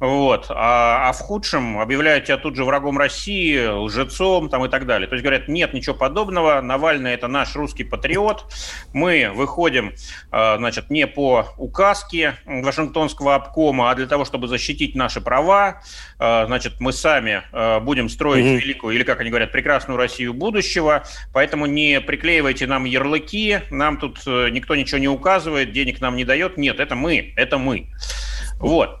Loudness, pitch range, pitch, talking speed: -19 LUFS, 125-155 Hz, 140 Hz, 155 wpm